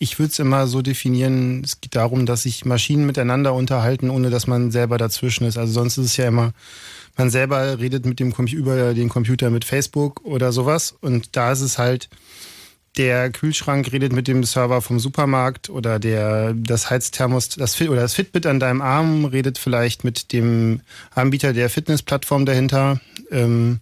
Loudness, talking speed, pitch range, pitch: -19 LUFS, 180 wpm, 120-135 Hz, 130 Hz